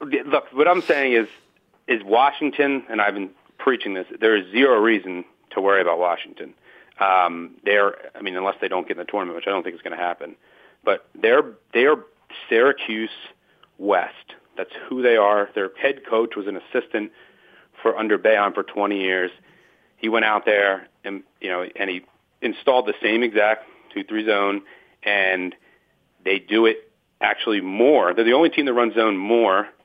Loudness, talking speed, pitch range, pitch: -21 LUFS, 180 wpm, 95-115 Hz, 105 Hz